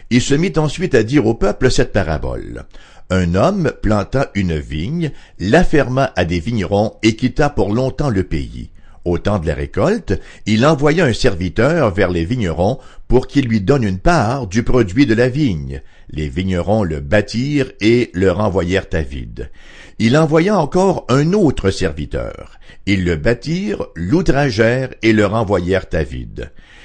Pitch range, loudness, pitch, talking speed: 90-135 Hz, -16 LUFS, 110 Hz, 165 wpm